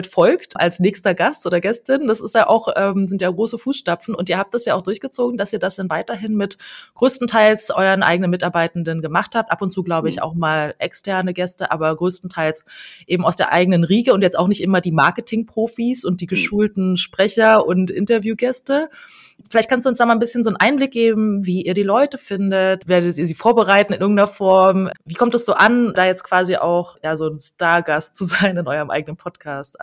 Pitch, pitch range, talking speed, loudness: 195 Hz, 175-225 Hz, 215 wpm, -17 LUFS